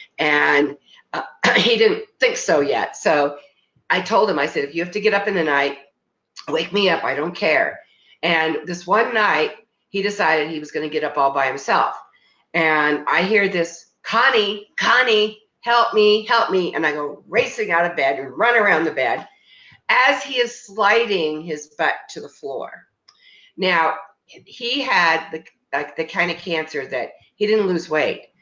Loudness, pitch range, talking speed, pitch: -19 LUFS, 155-220 Hz, 185 wpm, 180 Hz